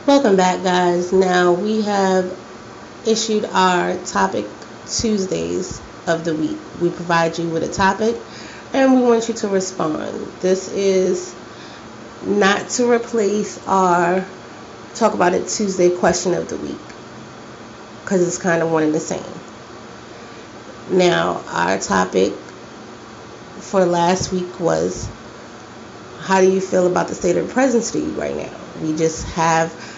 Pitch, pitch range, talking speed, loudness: 185 Hz, 170-195 Hz, 140 wpm, -18 LUFS